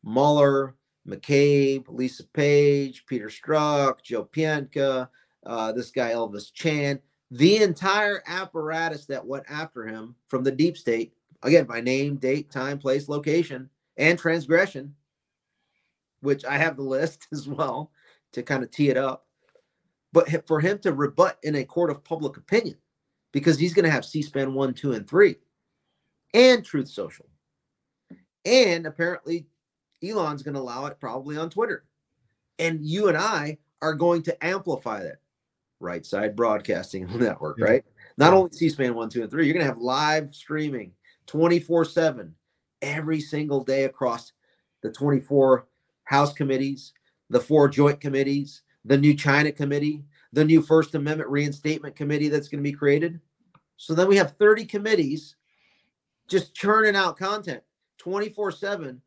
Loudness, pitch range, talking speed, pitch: -23 LUFS, 135-165 Hz, 150 wpm, 145 Hz